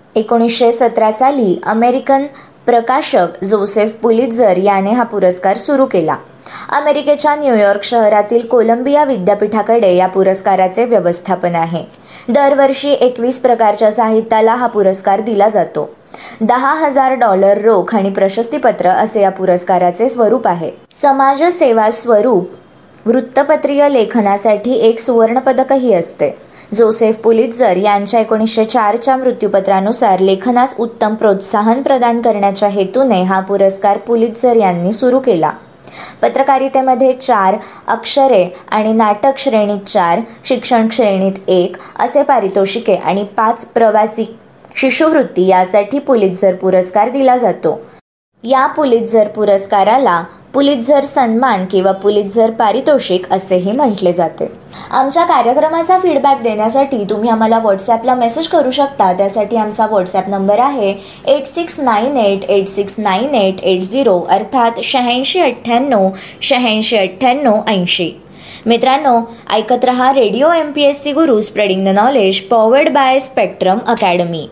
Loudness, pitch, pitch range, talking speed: -12 LUFS, 225 Hz, 200-260 Hz, 120 wpm